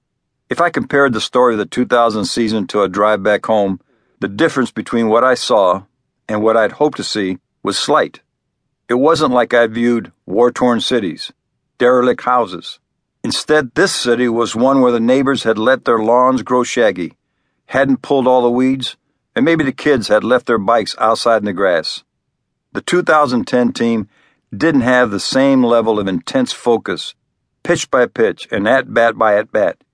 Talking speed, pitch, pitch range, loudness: 175 wpm, 120 Hz, 110-130 Hz, -14 LUFS